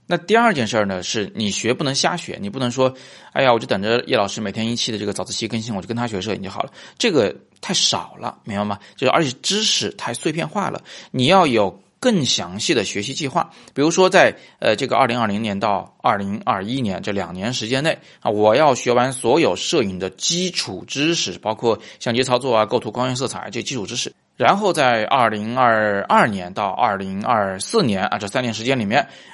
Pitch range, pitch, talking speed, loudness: 105-135 Hz, 120 Hz, 320 characters per minute, -19 LUFS